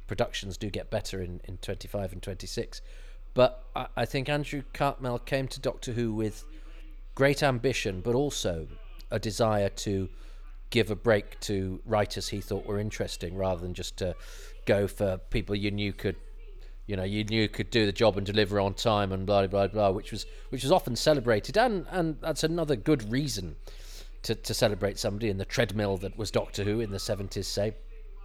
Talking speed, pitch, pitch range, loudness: 190 wpm, 105 Hz, 100-125 Hz, -29 LUFS